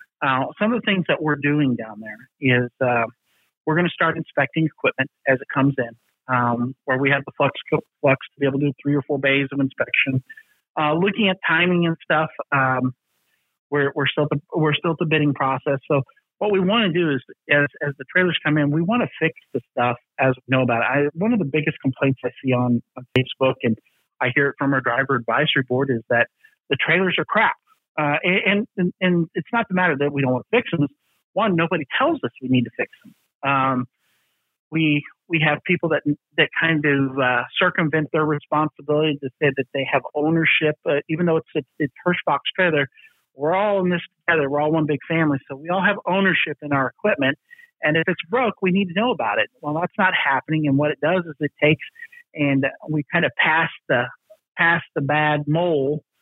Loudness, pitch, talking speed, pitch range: -21 LUFS, 150 Hz, 220 wpm, 135-175 Hz